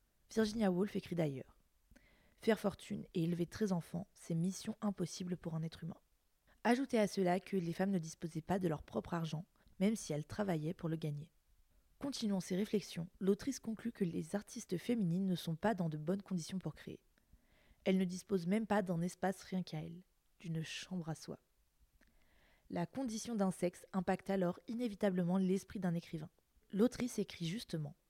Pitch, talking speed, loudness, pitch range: 185 Hz, 175 wpm, -39 LUFS, 170-205 Hz